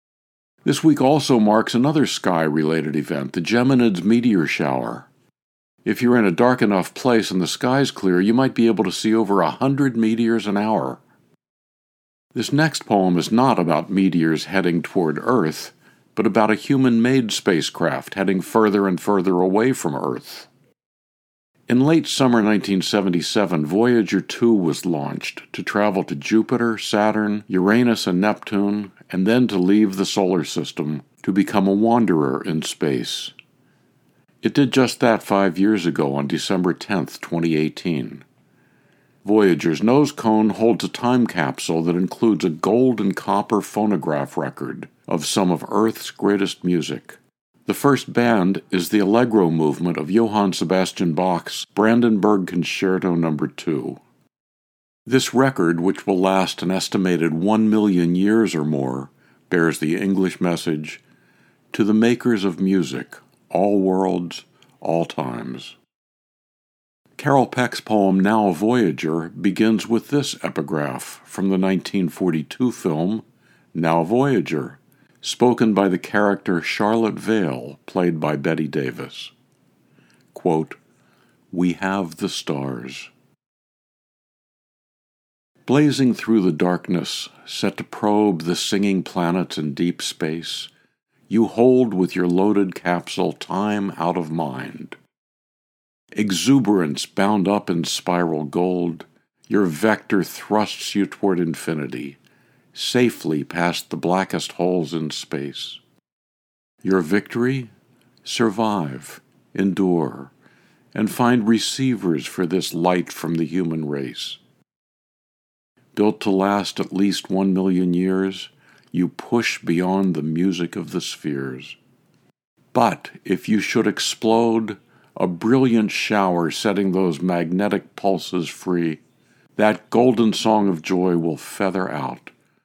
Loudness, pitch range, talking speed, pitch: -20 LUFS, 85-110 Hz, 130 wpm, 95 Hz